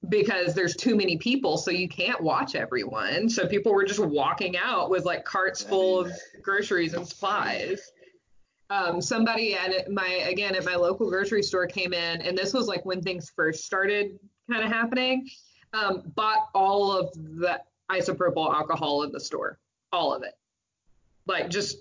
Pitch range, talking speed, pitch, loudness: 180-210 Hz, 170 wpm, 190 Hz, -26 LUFS